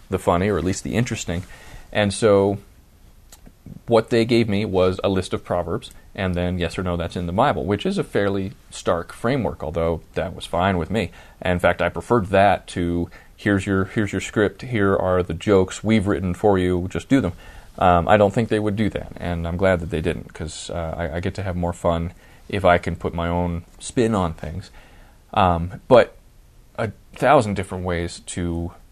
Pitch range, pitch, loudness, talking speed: 85-105 Hz, 95 Hz, -21 LUFS, 210 wpm